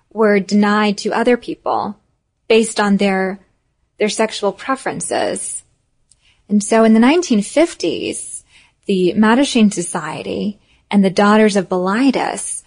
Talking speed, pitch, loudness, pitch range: 115 wpm, 210 Hz, -16 LUFS, 200-230 Hz